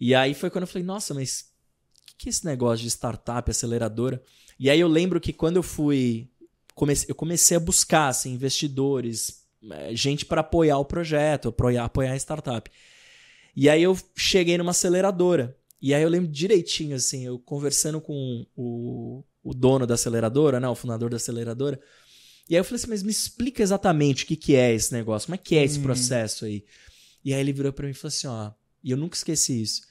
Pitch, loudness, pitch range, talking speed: 140 Hz, -24 LUFS, 125-170 Hz, 200 wpm